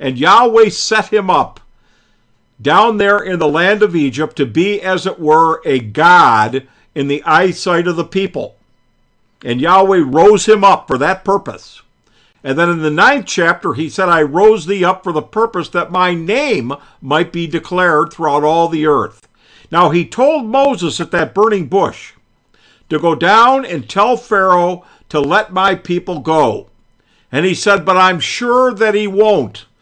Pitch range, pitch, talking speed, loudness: 155-200 Hz, 175 Hz, 175 wpm, -12 LUFS